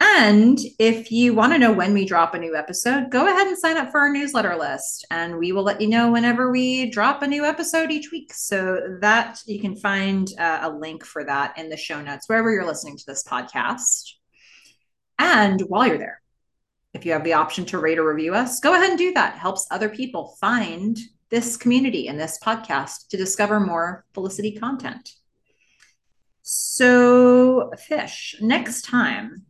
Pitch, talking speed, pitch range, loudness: 220 Hz, 185 wpm, 180-250 Hz, -20 LUFS